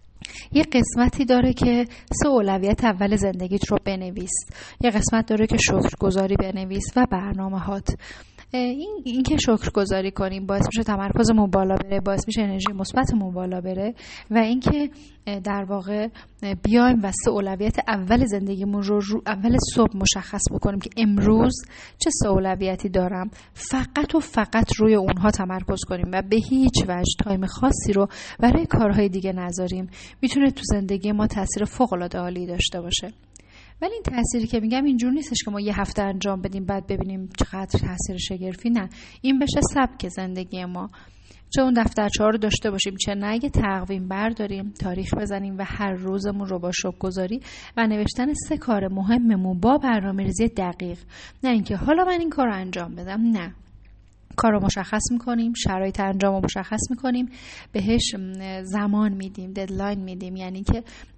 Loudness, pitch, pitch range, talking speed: -23 LUFS, 205 Hz, 190-230 Hz, 155 wpm